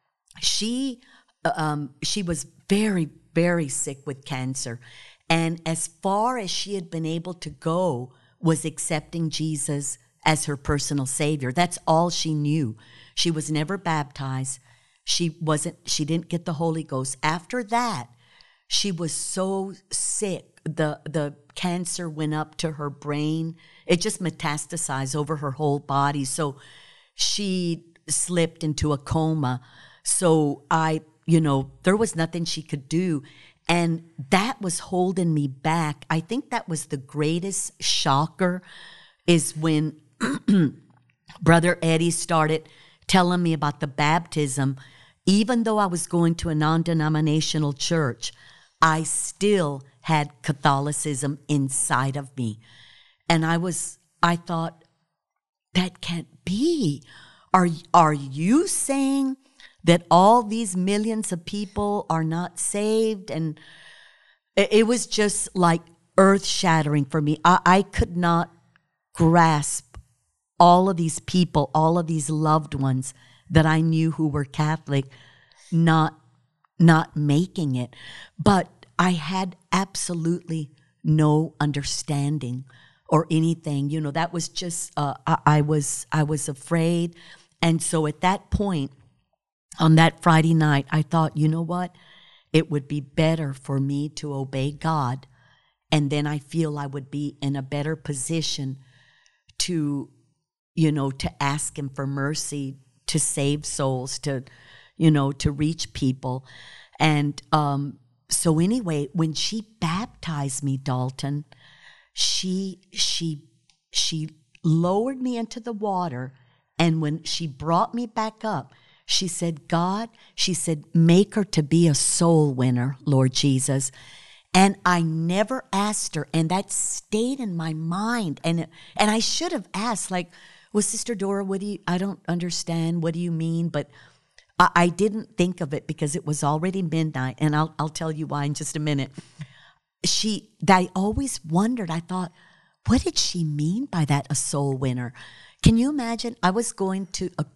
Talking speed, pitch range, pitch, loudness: 145 wpm, 145-180 Hz, 160 Hz, -24 LUFS